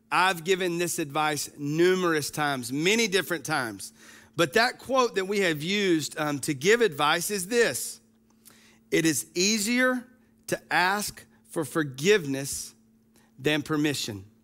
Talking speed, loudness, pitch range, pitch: 130 wpm, -26 LUFS, 125-195 Hz, 155 Hz